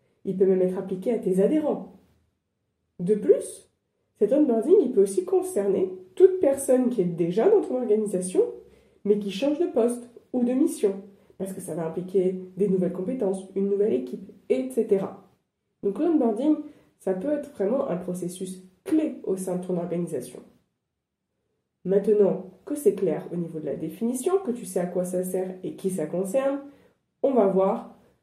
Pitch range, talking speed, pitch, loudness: 185-275 Hz, 170 wpm, 205 Hz, -25 LUFS